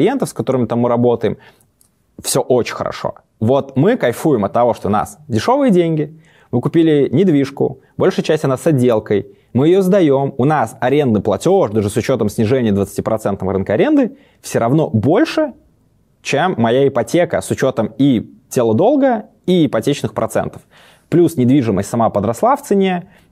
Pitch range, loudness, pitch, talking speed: 115-175 Hz, -15 LUFS, 140 Hz, 155 wpm